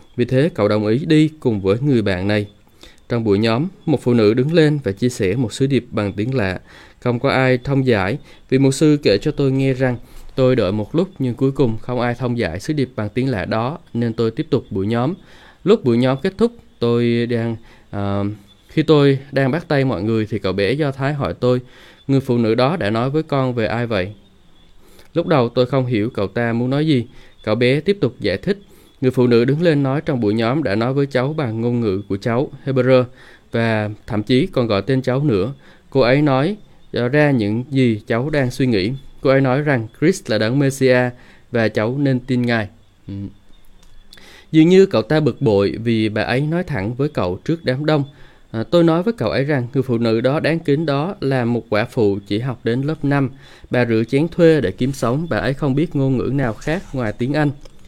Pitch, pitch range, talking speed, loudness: 125 Hz, 110-140 Hz, 230 wpm, -18 LUFS